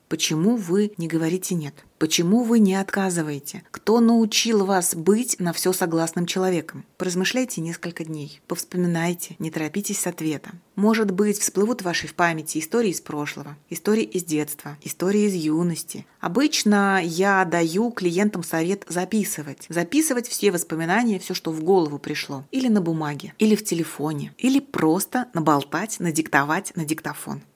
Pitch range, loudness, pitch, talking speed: 160-205 Hz, -23 LUFS, 180 Hz, 145 wpm